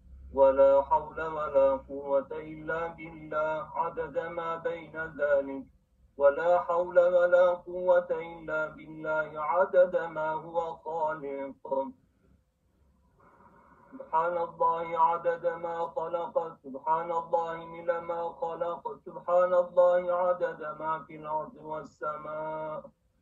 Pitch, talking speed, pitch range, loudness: 160 Hz, 95 wpm, 150-170 Hz, -29 LUFS